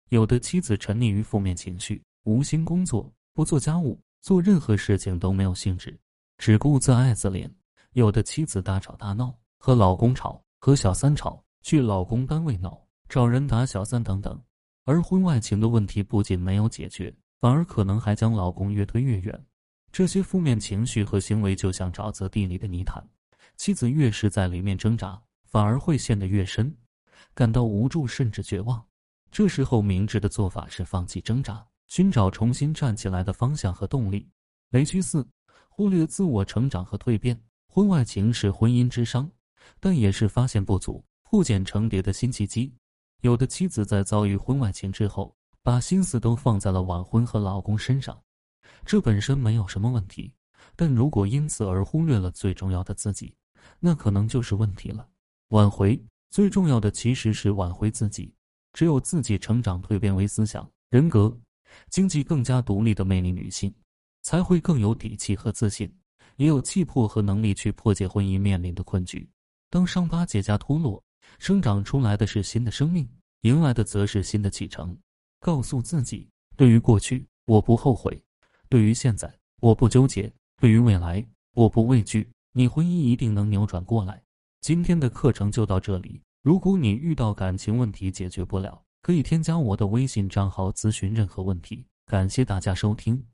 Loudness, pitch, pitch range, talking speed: -24 LUFS, 110 Hz, 100-130 Hz, 270 characters per minute